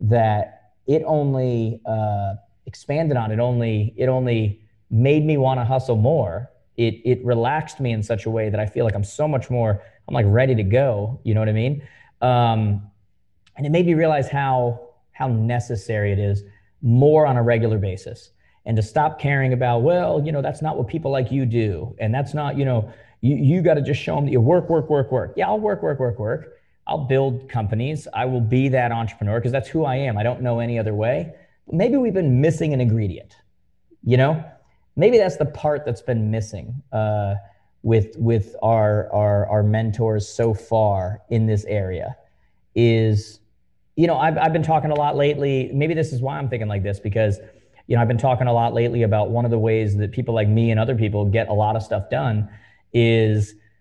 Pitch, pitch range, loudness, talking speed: 120 Hz, 110-135 Hz, -21 LUFS, 210 wpm